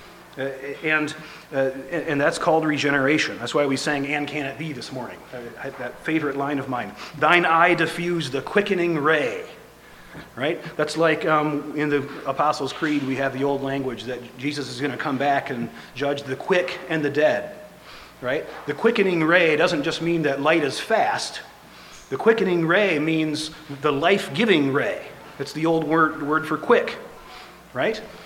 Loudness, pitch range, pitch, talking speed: -22 LUFS, 140-160 Hz, 150 Hz, 170 wpm